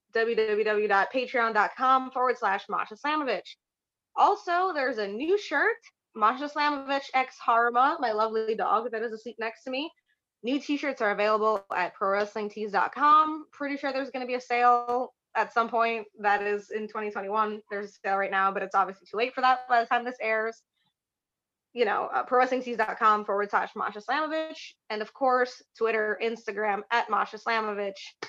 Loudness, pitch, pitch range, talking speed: -27 LUFS, 230 Hz, 215-265 Hz, 165 wpm